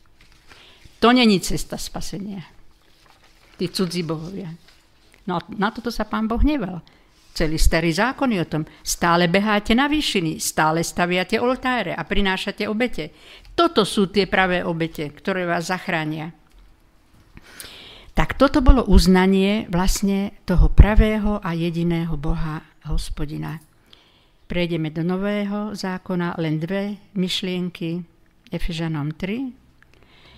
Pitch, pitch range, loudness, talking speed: 180 Hz, 165-205 Hz, -21 LUFS, 115 wpm